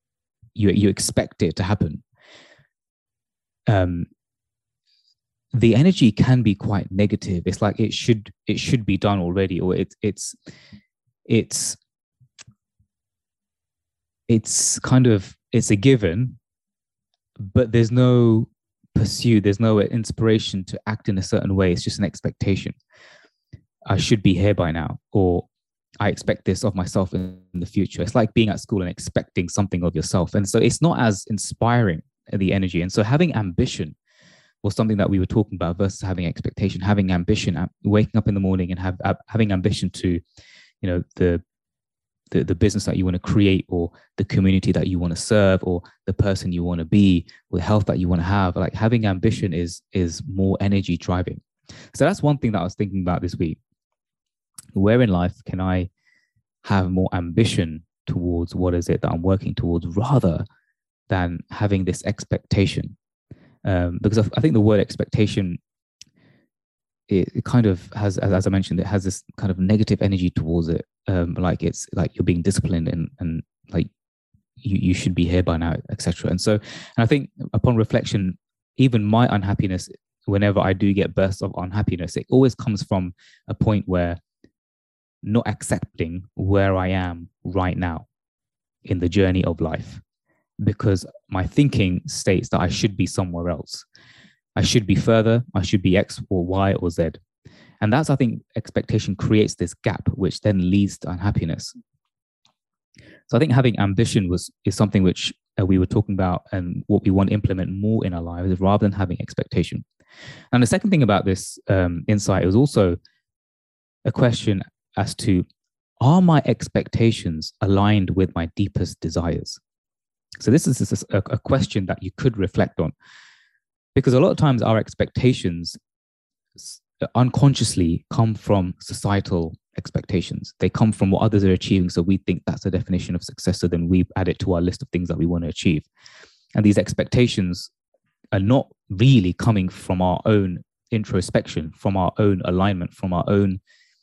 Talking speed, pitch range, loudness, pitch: 170 wpm, 90-110 Hz, -21 LUFS, 100 Hz